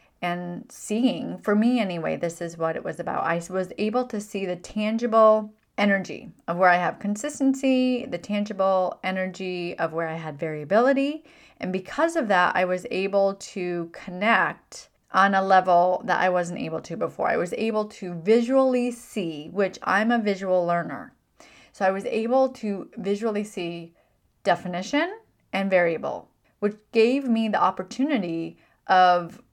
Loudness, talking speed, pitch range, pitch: -24 LUFS, 155 wpm, 180-230 Hz, 195 Hz